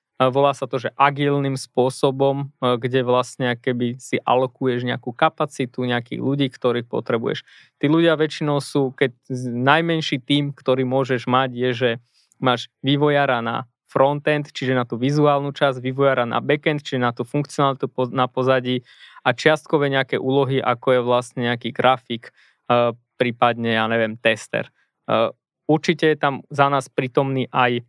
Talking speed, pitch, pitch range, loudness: 145 wpm, 130 Hz, 125-140 Hz, -21 LUFS